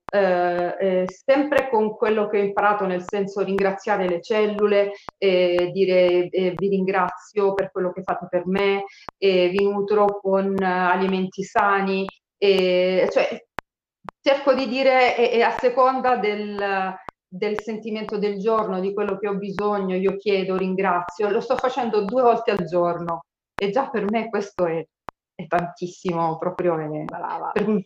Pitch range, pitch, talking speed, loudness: 185-210 Hz, 195 Hz, 155 wpm, -22 LUFS